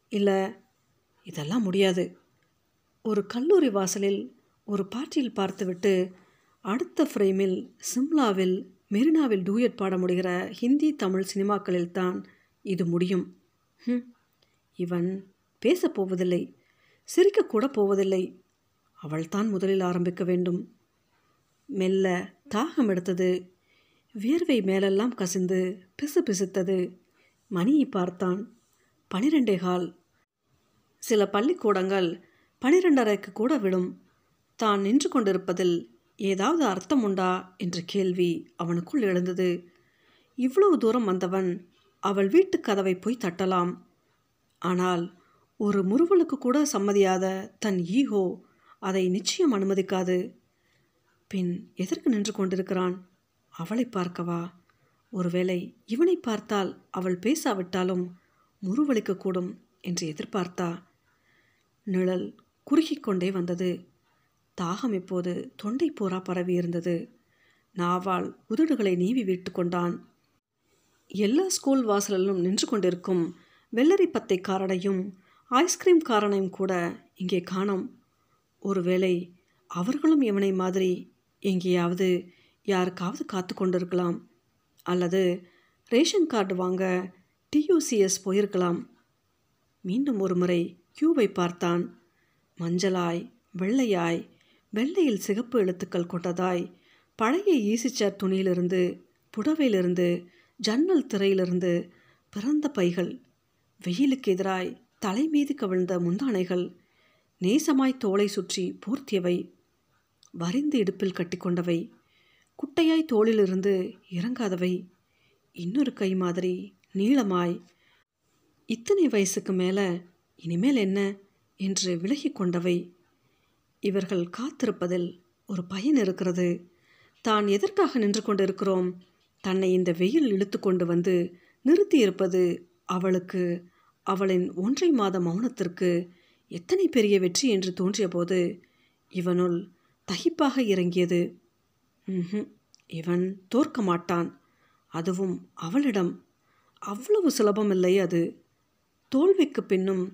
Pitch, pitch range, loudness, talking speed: 190 Hz, 180-220 Hz, -27 LUFS, 85 wpm